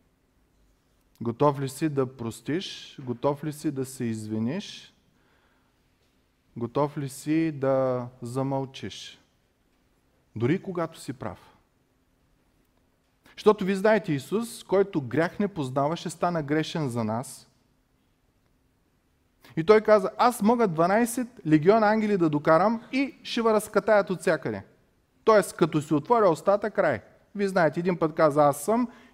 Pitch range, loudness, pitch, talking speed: 140-210 Hz, -25 LUFS, 165 Hz, 125 wpm